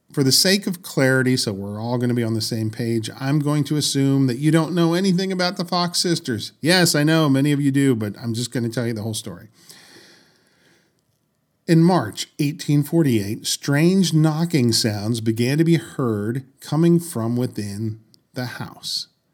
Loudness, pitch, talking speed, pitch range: -20 LUFS, 135 Hz, 185 wpm, 115-165 Hz